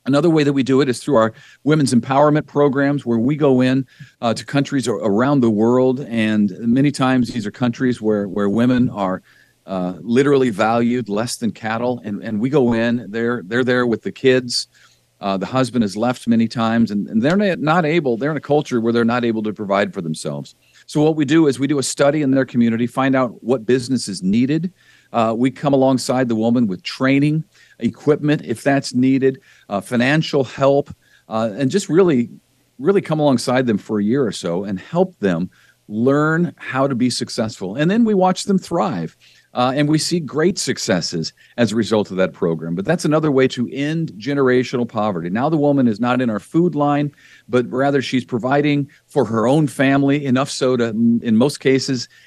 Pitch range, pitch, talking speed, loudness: 115-145 Hz, 130 Hz, 200 wpm, -18 LUFS